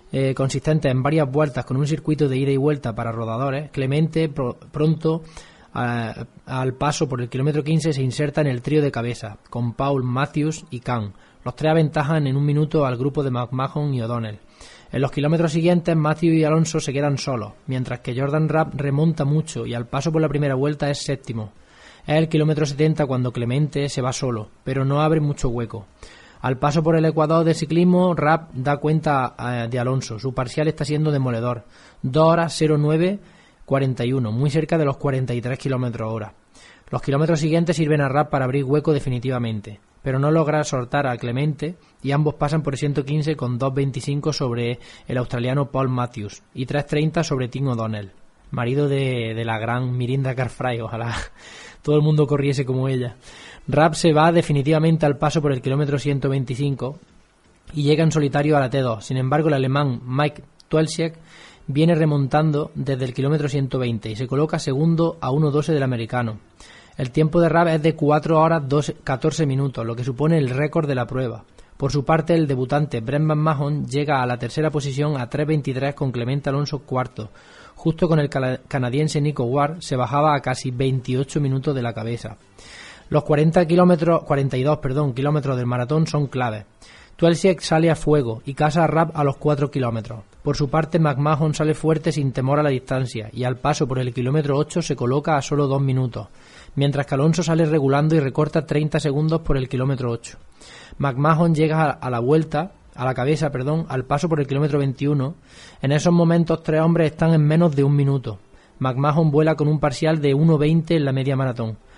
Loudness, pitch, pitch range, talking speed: -21 LUFS, 145 Hz, 130-155 Hz, 185 wpm